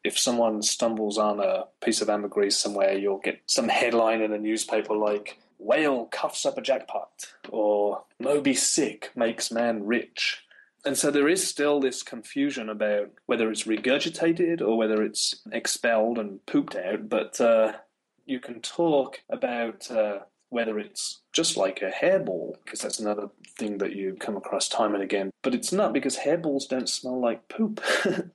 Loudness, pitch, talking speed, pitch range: -26 LUFS, 115 Hz, 165 wpm, 105-140 Hz